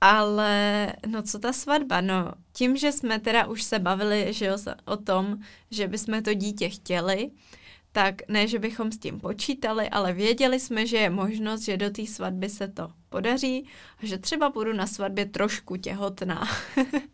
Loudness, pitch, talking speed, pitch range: -27 LUFS, 210 Hz, 170 wpm, 195-225 Hz